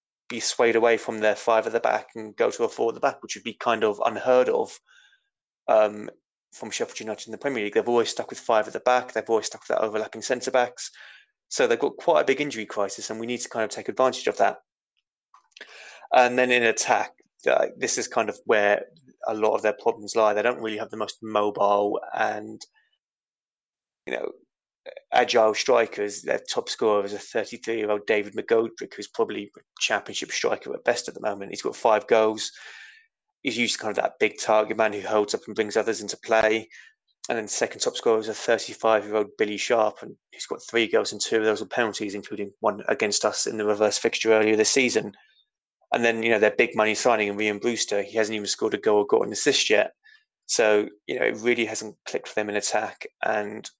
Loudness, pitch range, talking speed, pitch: -24 LUFS, 105-130 Hz, 230 wpm, 110 Hz